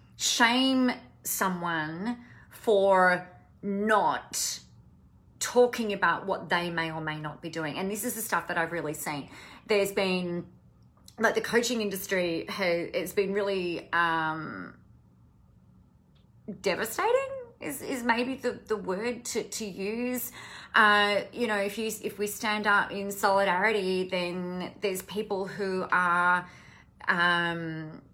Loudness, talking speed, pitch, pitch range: -28 LUFS, 130 wpm, 195 Hz, 175-220 Hz